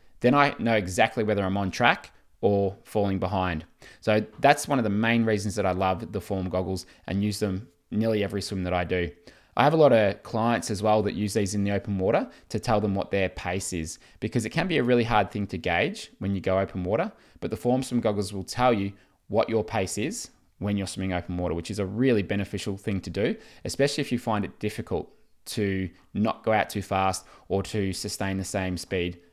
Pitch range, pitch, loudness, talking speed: 95-110 Hz, 100 Hz, -26 LUFS, 230 wpm